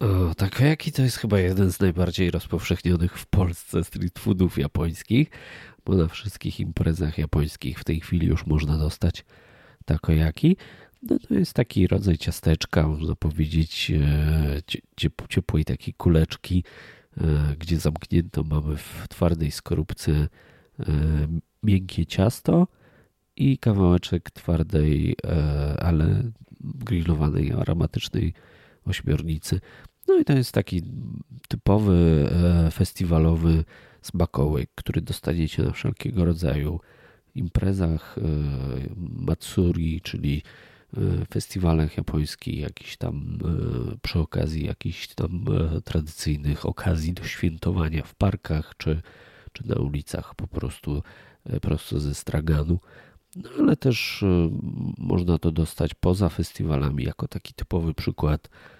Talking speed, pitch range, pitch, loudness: 105 wpm, 75-95 Hz, 85 Hz, -25 LUFS